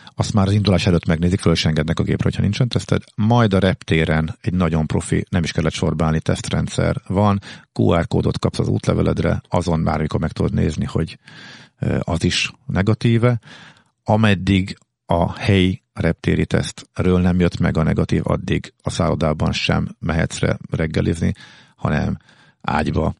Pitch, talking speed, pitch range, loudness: 90 Hz, 155 wpm, 85-105 Hz, -19 LUFS